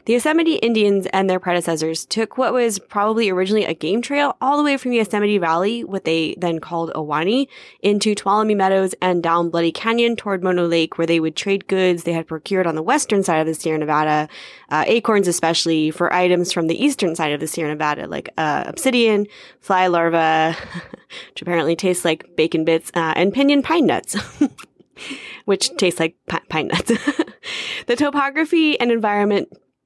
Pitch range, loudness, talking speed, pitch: 165-230 Hz, -19 LUFS, 185 wpm, 190 Hz